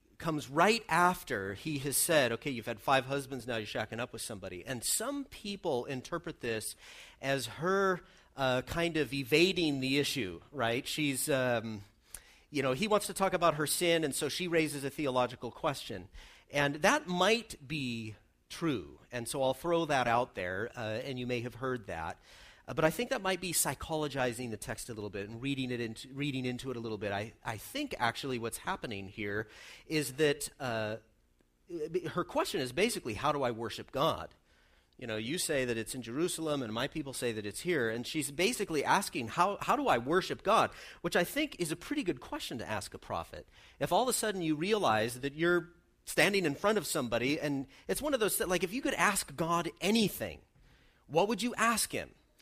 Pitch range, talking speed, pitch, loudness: 120-170 Hz, 205 wpm, 140 Hz, -33 LUFS